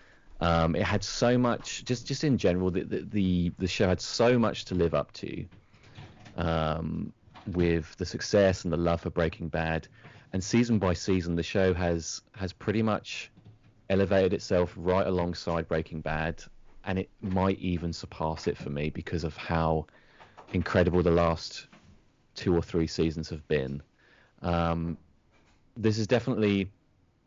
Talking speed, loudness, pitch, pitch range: 155 wpm, -29 LUFS, 90 Hz, 85-105 Hz